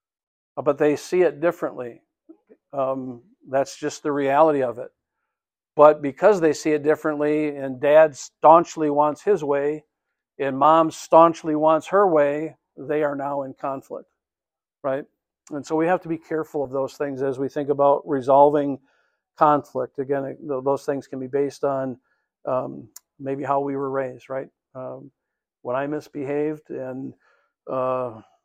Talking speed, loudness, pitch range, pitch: 150 wpm, -22 LUFS, 135-155 Hz, 145 Hz